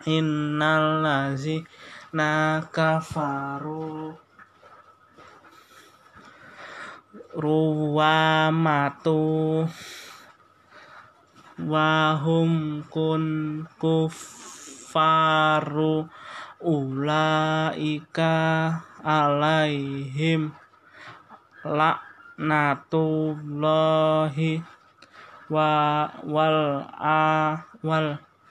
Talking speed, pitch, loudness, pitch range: 35 wpm, 155 Hz, -24 LUFS, 155-160 Hz